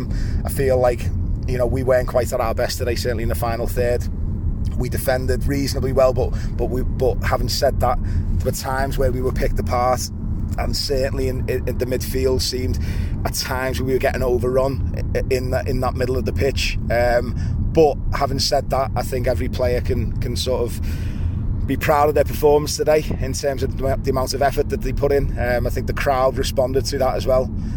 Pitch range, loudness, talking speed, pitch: 100-130 Hz, -21 LUFS, 210 wpm, 120 Hz